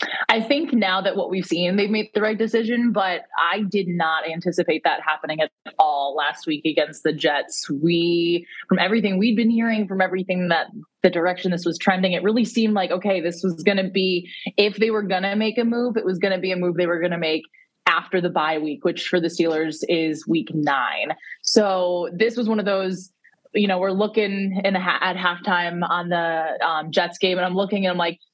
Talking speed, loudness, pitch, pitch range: 225 wpm, -21 LUFS, 185 Hz, 170-205 Hz